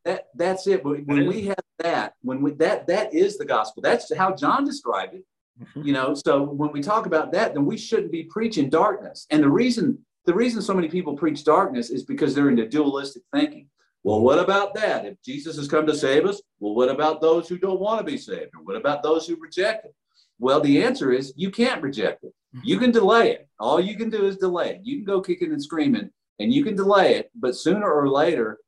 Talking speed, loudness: 230 wpm, -22 LUFS